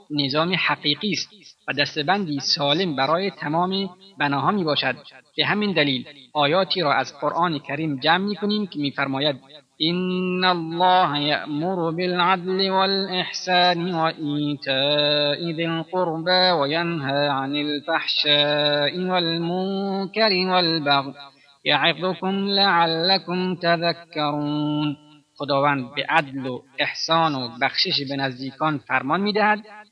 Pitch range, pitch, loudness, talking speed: 145-185 Hz, 160 Hz, -21 LUFS, 105 wpm